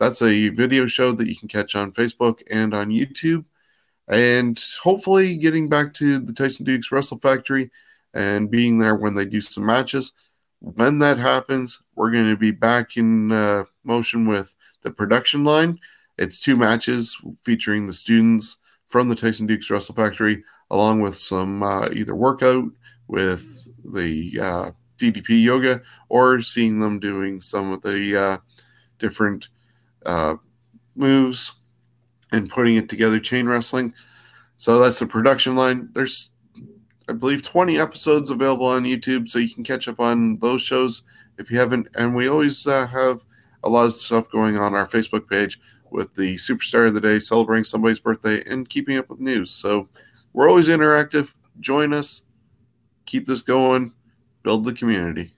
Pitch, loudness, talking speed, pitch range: 120 Hz, -20 LUFS, 165 wpm, 110-130 Hz